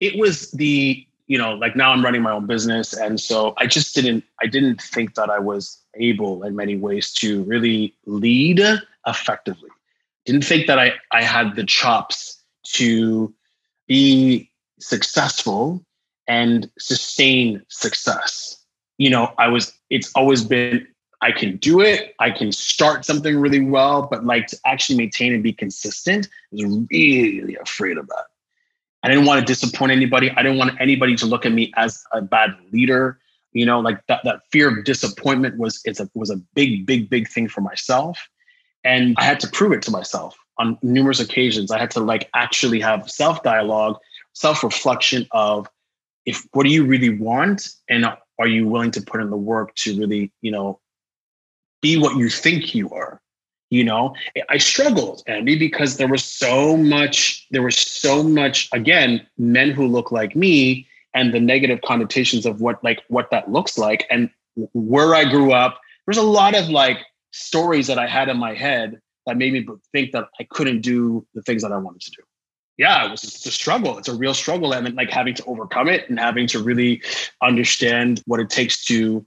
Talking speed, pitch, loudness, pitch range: 185 wpm, 125 Hz, -18 LUFS, 115-140 Hz